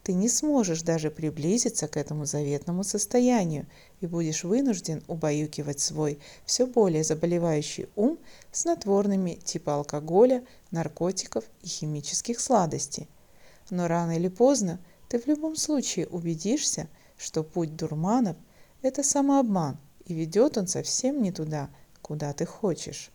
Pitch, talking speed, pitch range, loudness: 175 Hz, 125 wpm, 155-230 Hz, -27 LUFS